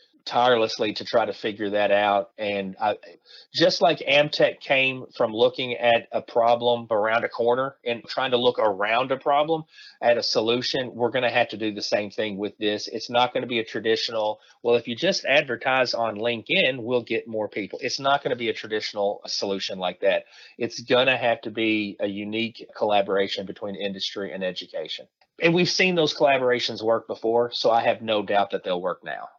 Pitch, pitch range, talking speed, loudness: 115 Hz, 110-125 Hz, 200 wpm, -24 LUFS